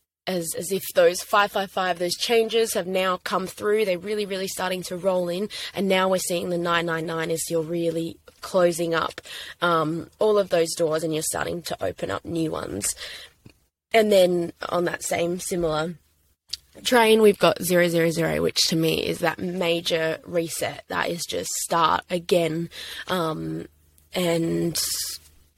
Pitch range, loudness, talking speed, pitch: 165-185 Hz, -24 LUFS, 170 wpm, 175 Hz